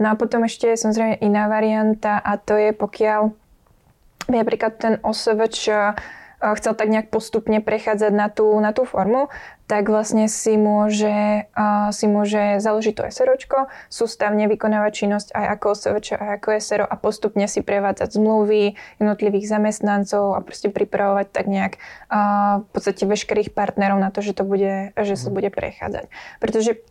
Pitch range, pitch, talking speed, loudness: 205-220 Hz, 210 Hz, 160 wpm, -20 LUFS